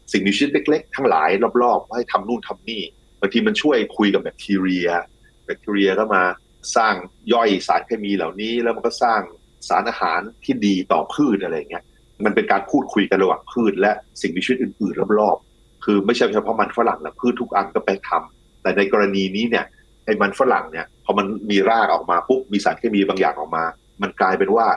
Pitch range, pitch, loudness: 95-115 Hz, 100 Hz, -20 LUFS